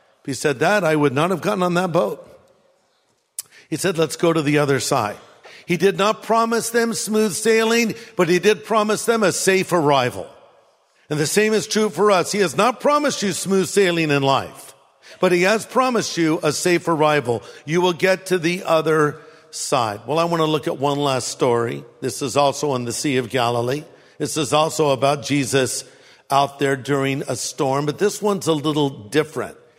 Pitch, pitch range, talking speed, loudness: 160 Hz, 140-200 Hz, 200 wpm, -19 LUFS